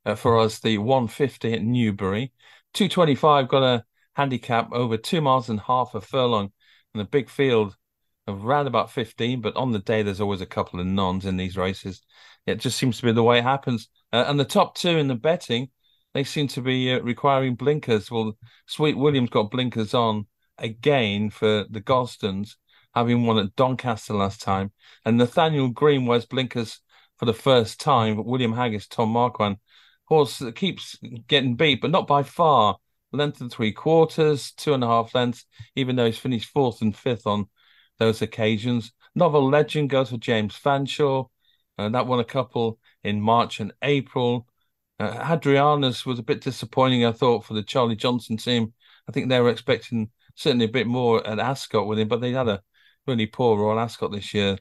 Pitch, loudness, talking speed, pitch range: 120 Hz, -23 LUFS, 195 wpm, 110-135 Hz